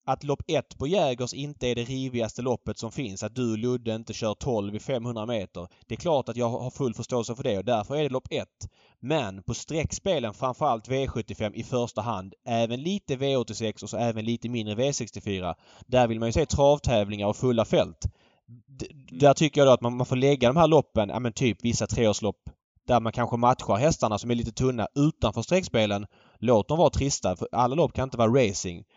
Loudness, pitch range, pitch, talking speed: -26 LUFS, 110-130 Hz, 120 Hz, 215 wpm